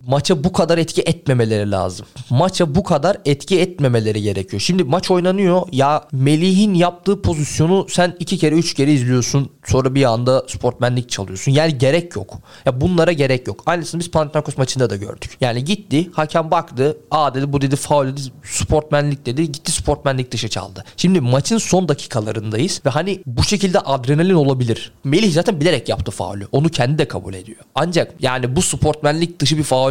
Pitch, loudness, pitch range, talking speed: 145 Hz, -17 LUFS, 125-170 Hz, 175 wpm